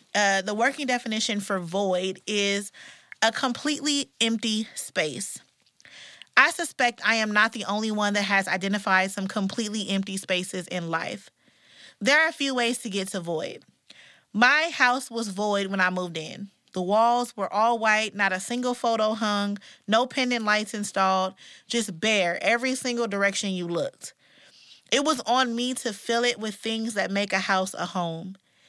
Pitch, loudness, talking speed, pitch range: 210 Hz, -25 LUFS, 170 wpm, 195-235 Hz